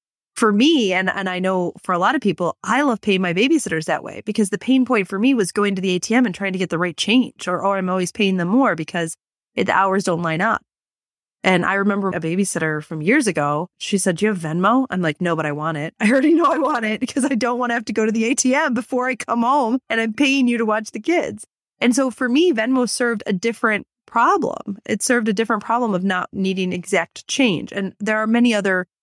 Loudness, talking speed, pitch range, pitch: -19 LUFS, 255 wpm, 185-245 Hz, 215 Hz